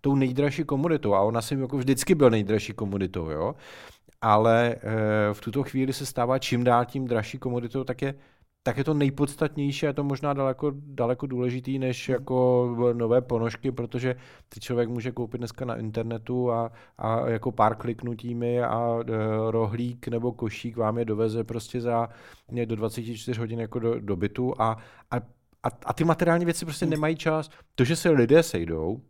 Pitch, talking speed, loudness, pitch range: 120 Hz, 170 wpm, -26 LUFS, 115-135 Hz